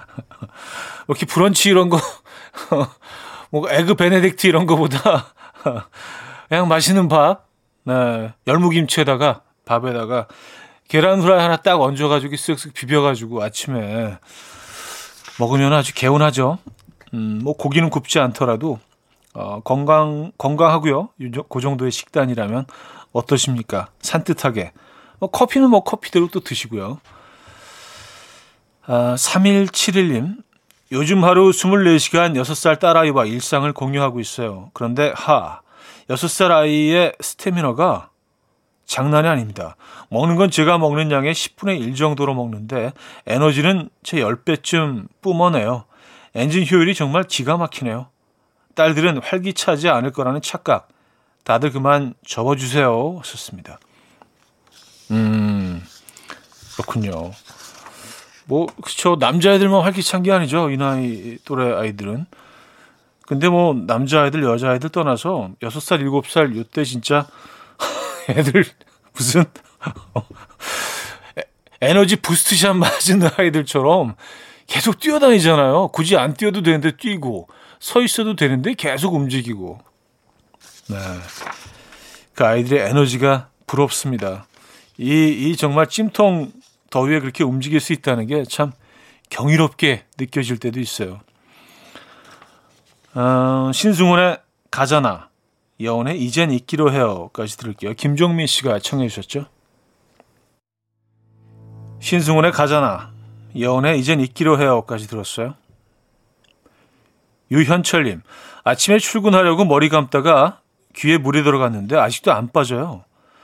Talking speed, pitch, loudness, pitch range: 255 characters per minute, 145 Hz, -17 LUFS, 120-170 Hz